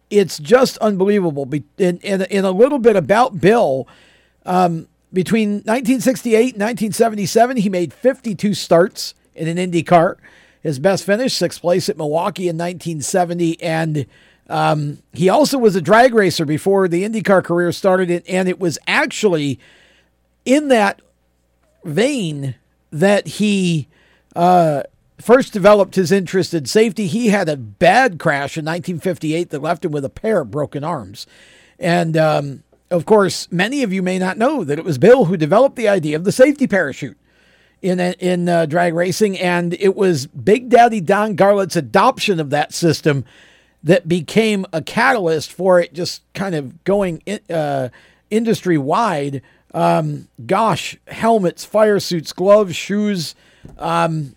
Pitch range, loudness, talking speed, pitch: 160-205 Hz, -16 LUFS, 150 wpm, 180 Hz